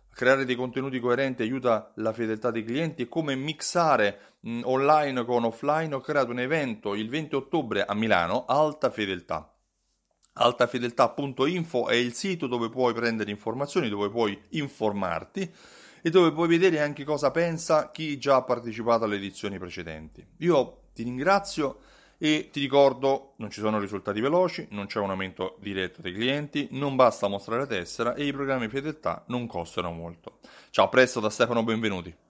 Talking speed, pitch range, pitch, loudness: 160 wpm, 110-145 Hz, 125 Hz, -26 LUFS